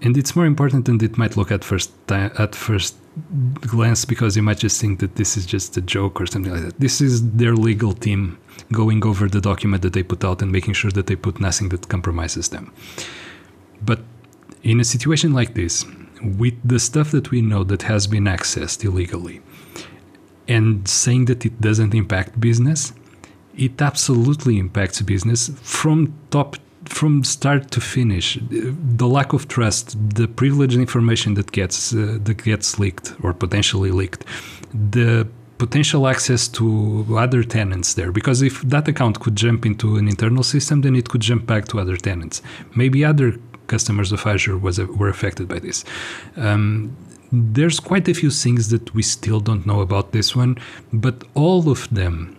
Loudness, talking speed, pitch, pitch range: -19 LUFS, 180 wpm, 110 Hz, 100-125 Hz